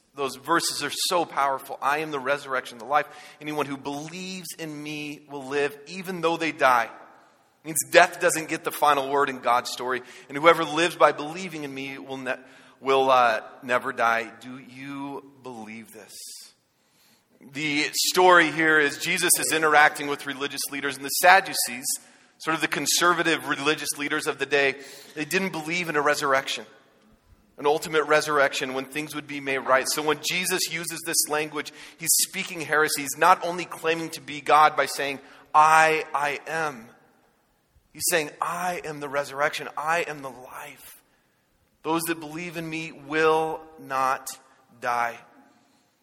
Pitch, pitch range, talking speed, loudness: 150 Hz, 135-160 Hz, 165 wpm, -24 LUFS